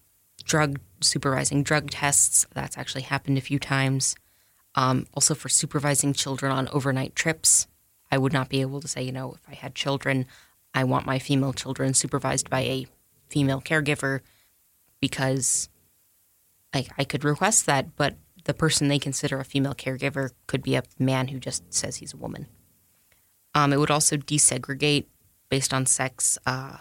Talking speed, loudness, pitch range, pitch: 165 wpm, -24 LUFS, 130-140 Hz, 135 Hz